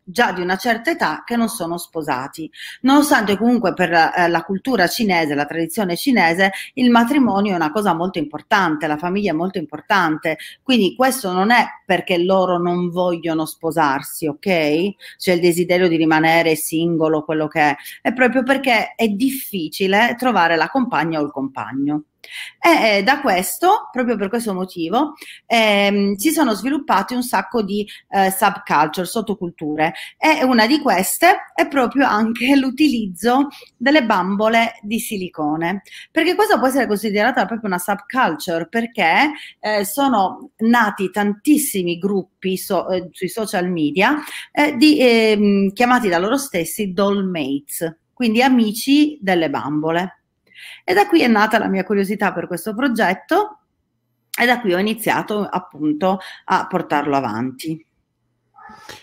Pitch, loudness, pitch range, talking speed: 200 Hz, -18 LUFS, 175-250 Hz, 145 wpm